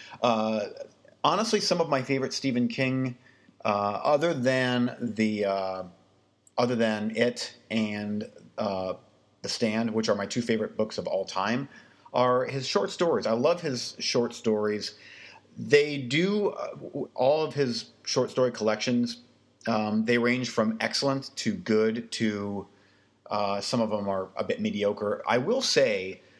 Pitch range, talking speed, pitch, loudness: 105-130 Hz, 150 wpm, 115 Hz, -27 LUFS